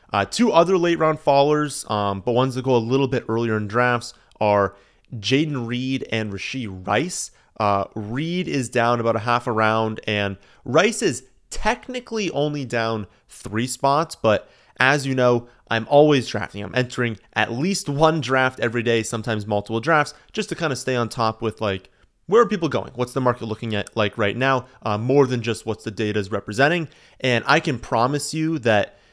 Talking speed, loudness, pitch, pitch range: 195 wpm, -21 LUFS, 120 Hz, 110-140 Hz